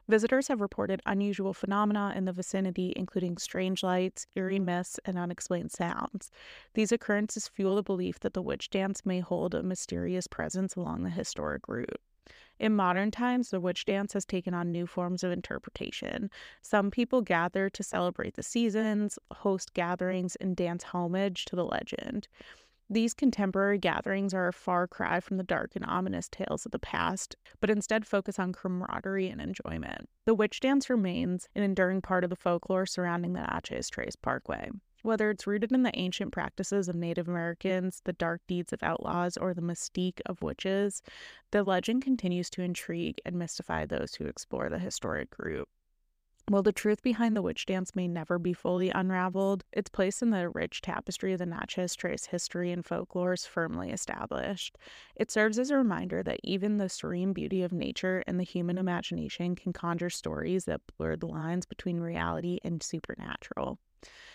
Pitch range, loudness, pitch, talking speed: 180-205 Hz, -32 LUFS, 185 Hz, 175 wpm